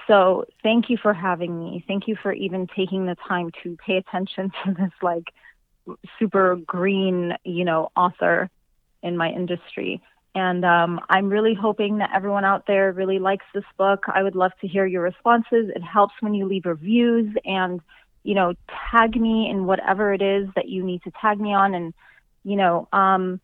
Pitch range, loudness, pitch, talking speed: 180-200 Hz, -22 LUFS, 190 Hz, 185 wpm